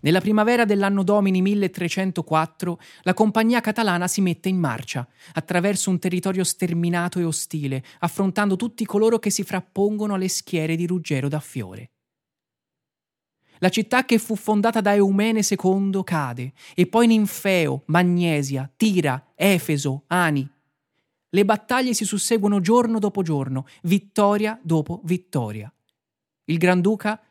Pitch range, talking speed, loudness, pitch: 160-205 Hz, 125 wpm, -22 LUFS, 185 Hz